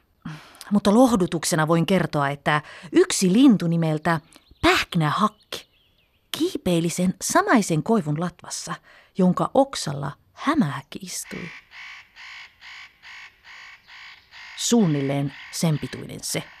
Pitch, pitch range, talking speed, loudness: 180 Hz, 155-230 Hz, 80 wpm, -22 LUFS